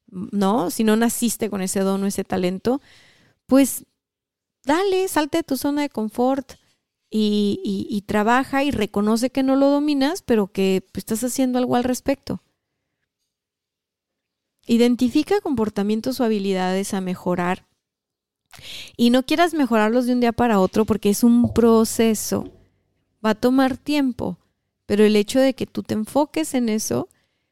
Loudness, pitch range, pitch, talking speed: -20 LUFS, 205-265 Hz, 235 Hz, 150 wpm